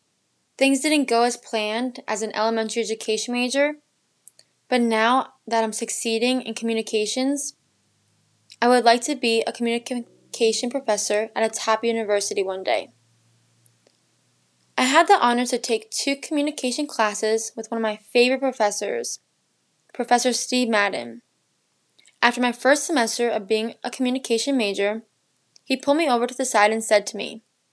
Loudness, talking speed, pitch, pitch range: -22 LUFS, 150 wpm, 230 Hz, 215-250 Hz